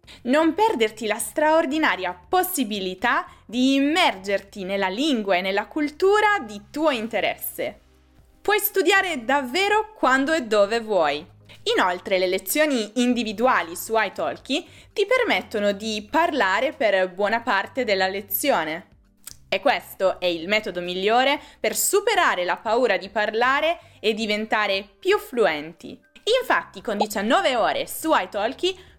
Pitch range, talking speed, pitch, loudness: 205-320 Hz, 120 wpm, 245 Hz, -22 LUFS